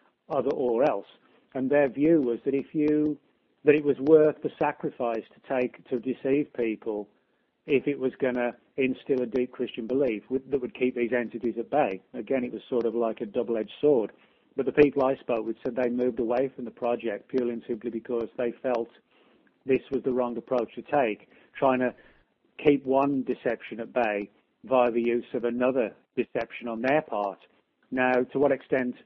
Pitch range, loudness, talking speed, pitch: 120-135 Hz, -27 LUFS, 195 wpm, 125 Hz